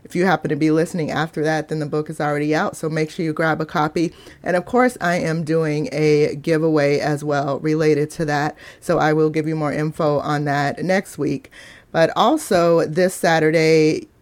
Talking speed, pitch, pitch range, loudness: 205 wpm, 155 Hz, 150-165 Hz, -19 LUFS